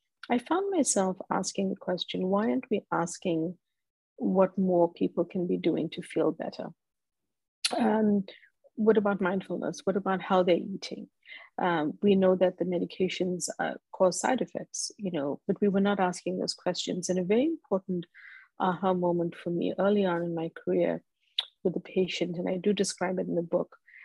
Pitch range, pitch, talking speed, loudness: 180-205 Hz, 185 Hz, 175 wpm, -29 LUFS